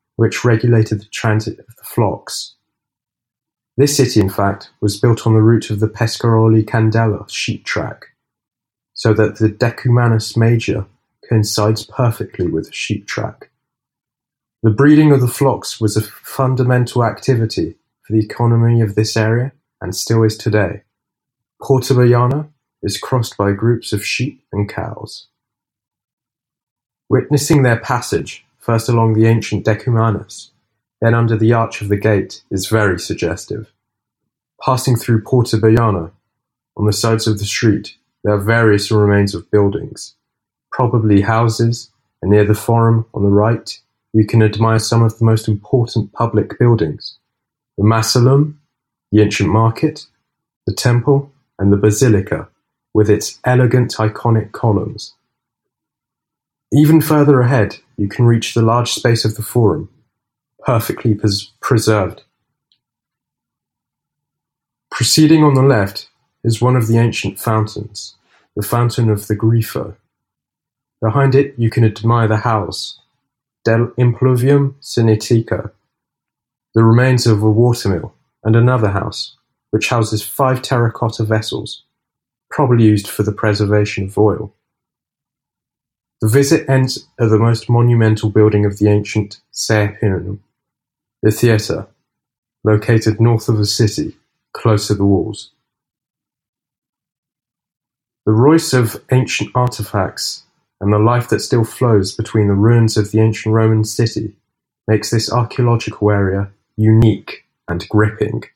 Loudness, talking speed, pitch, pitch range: -15 LUFS, 130 wpm, 115 Hz, 105-125 Hz